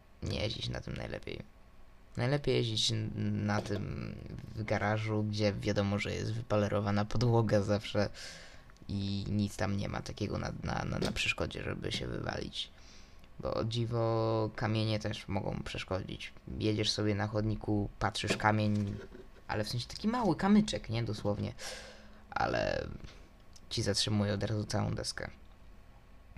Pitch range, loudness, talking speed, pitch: 105-110 Hz, -34 LUFS, 135 wpm, 105 Hz